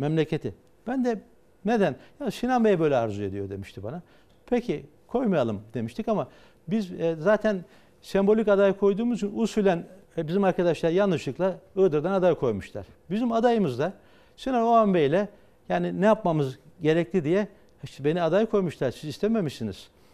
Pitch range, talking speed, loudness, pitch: 155-210 Hz, 145 wpm, -26 LUFS, 190 Hz